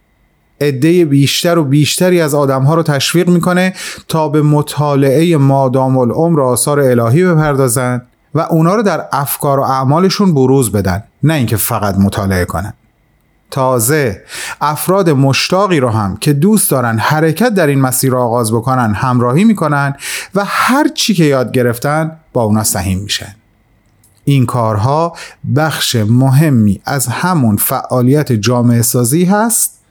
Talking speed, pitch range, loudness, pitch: 135 wpm, 120-160 Hz, -12 LUFS, 135 Hz